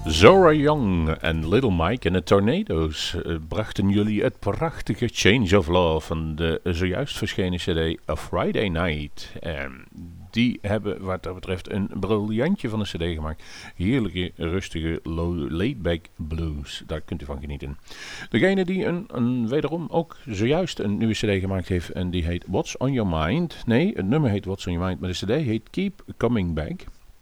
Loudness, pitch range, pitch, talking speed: -24 LUFS, 85-110 Hz, 95 Hz, 175 wpm